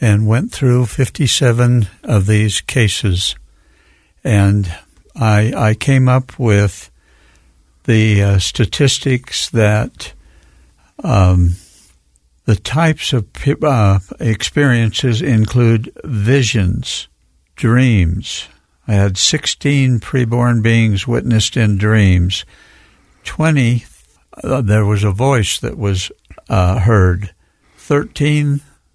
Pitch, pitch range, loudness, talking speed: 110 Hz, 90-125 Hz, -14 LUFS, 95 wpm